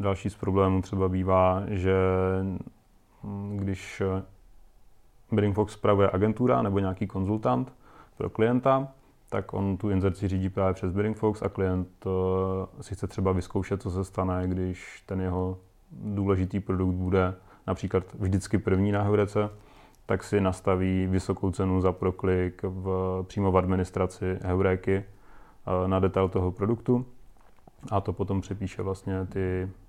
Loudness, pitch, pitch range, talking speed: -28 LUFS, 95 Hz, 95-100 Hz, 135 wpm